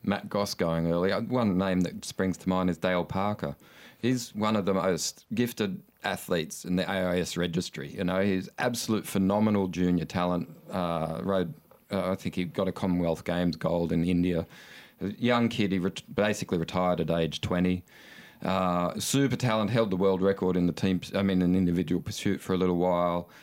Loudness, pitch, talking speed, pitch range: -28 LUFS, 95 Hz, 190 wpm, 90-100 Hz